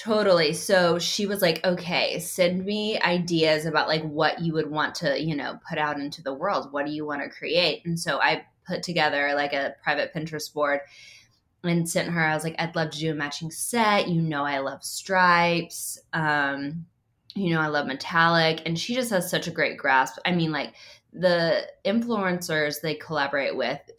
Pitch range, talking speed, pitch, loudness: 150-180 Hz, 200 wpm, 160 Hz, -25 LUFS